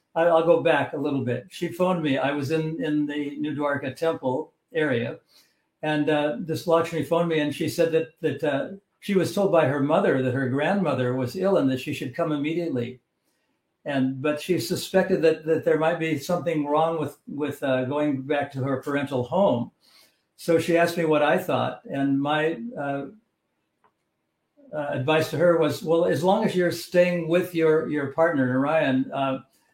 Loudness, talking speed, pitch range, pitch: -24 LUFS, 190 wpm, 140-170 Hz, 155 Hz